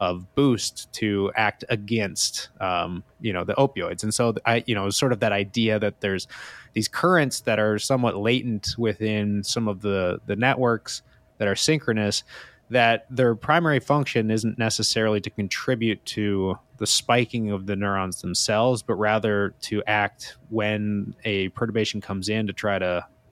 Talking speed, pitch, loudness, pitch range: 160 wpm, 110 Hz, -24 LUFS, 100-120 Hz